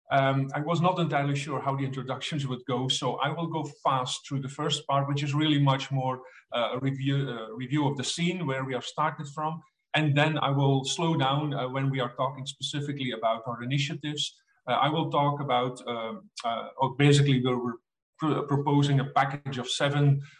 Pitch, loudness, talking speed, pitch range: 140 Hz, -28 LUFS, 205 wpm, 130-150 Hz